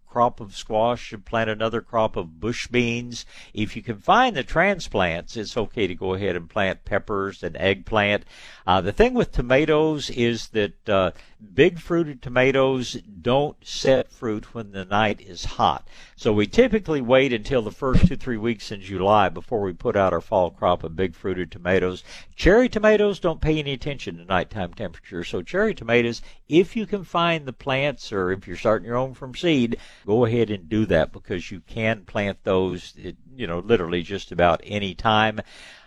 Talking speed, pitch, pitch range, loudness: 185 wpm, 115 Hz, 100-130 Hz, -23 LUFS